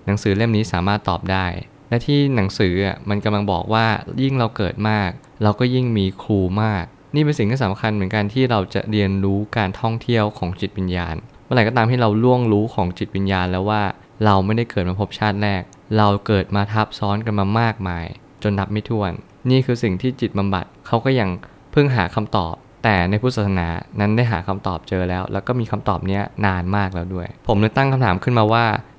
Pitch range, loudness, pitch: 95-115 Hz, -20 LUFS, 105 Hz